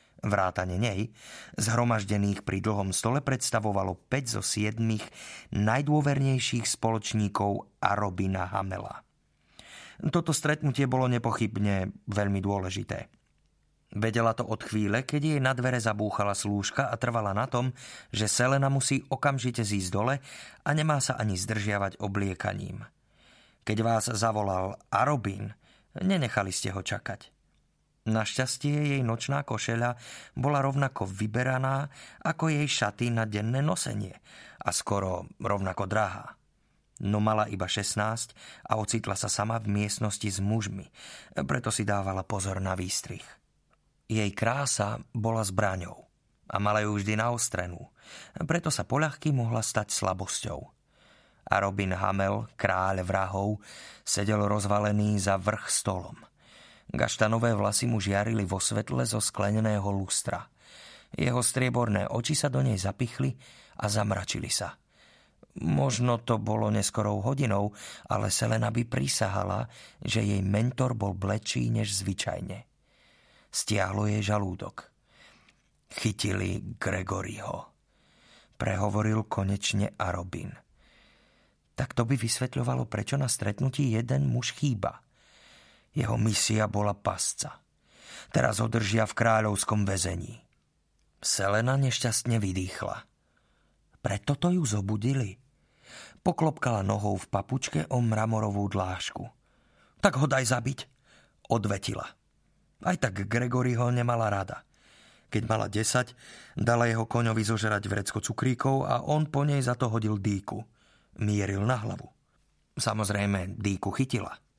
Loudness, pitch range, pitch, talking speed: -29 LUFS, 100-125 Hz, 110 Hz, 120 wpm